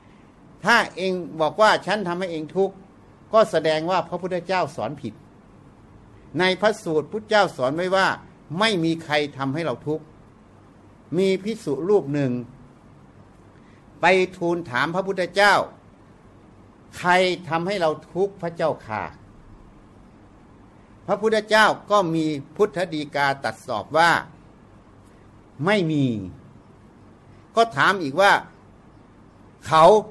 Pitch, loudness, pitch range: 160 Hz, -22 LUFS, 115-190 Hz